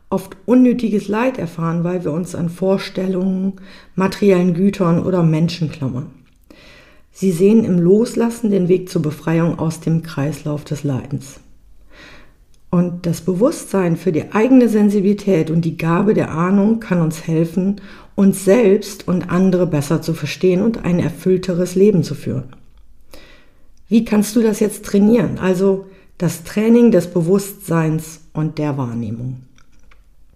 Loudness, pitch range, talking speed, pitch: -17 LUFS, 160-200 Hz, 135 wpm, 180 Hz